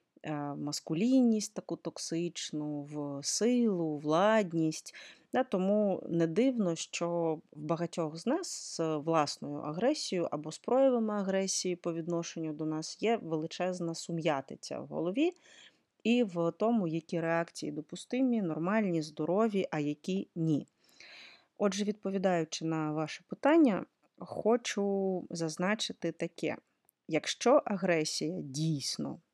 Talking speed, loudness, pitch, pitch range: 110 wpm, -32 LUFS, 170 Hz, 160-210 Hz